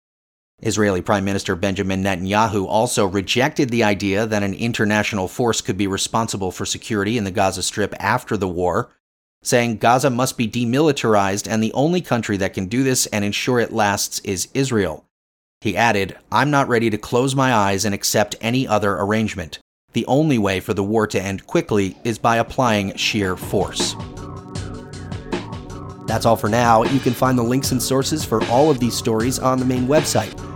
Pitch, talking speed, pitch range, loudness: 110 Hz, 180 wpm, 100-125 Hz, -19 LUFS